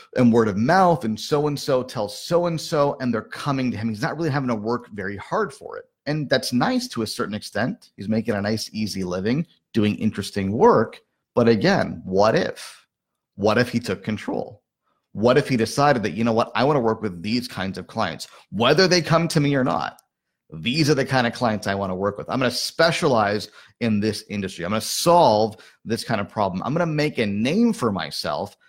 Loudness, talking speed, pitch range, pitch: -22 LUFS, 230 wpm, 110-150 Hz, 120 Hz